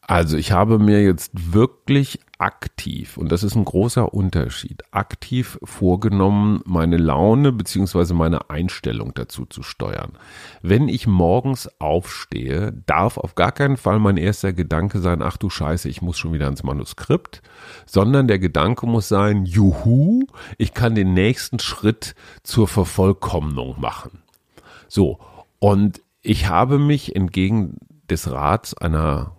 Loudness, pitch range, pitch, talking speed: -19 LUFS, 85-110 Hz, 95 Hz, 140 wpm